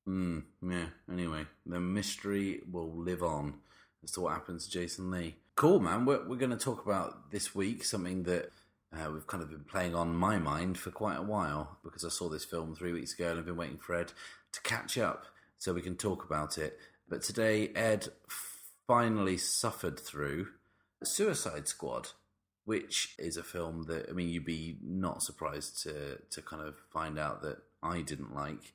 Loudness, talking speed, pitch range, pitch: -36 LUFS, 195 wpm, 85-100 Hz, 90 Hz